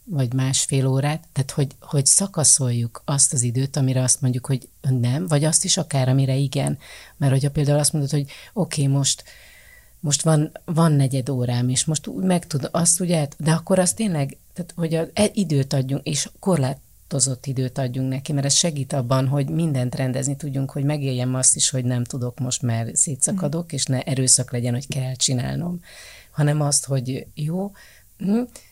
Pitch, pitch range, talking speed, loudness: 140 Hz, 130-155 Hz, 175 wpm, -21 LUFS